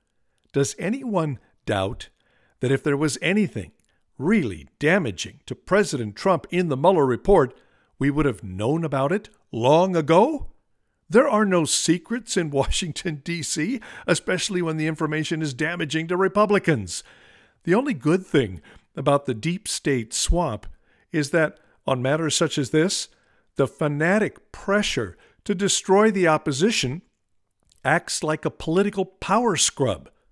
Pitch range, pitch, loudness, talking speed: 145-190 Hz, 160 Hz, -23 LUFS, 135 wpm